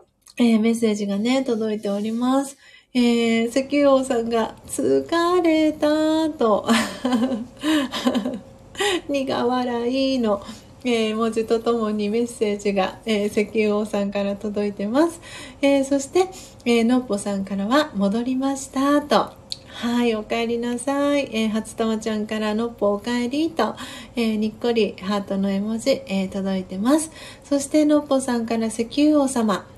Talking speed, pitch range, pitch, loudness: 280 characters per minute, 215-270 Hz, 235 Hz, -22 LUFS